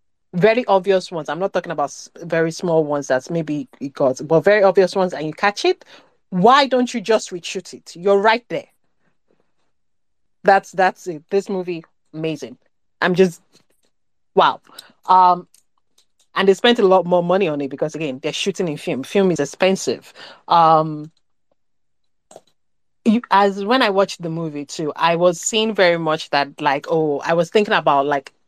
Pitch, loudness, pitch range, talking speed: 180 Hz, -18 LUFS, 160-200 Hz, 170 wpm